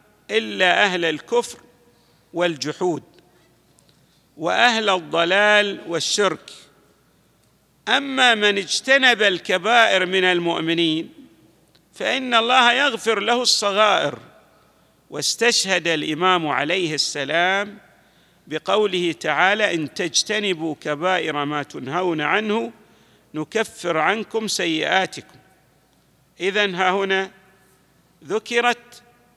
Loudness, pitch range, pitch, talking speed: -19 LUFS, 165-215 Hz, 190 Hz, 75 wpm